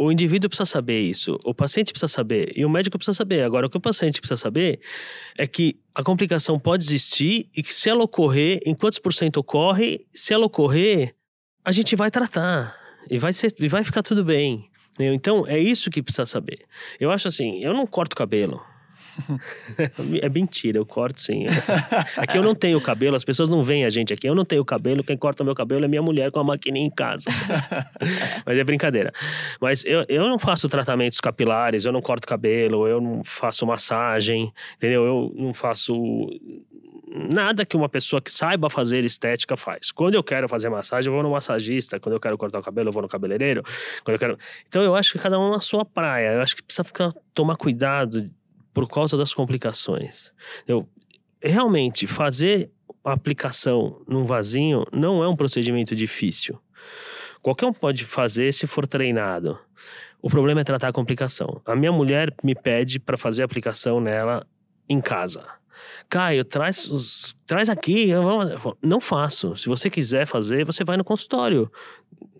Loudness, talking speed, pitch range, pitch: -22 LUFS, 190 wpm, 130-185 Hz, 145 Hz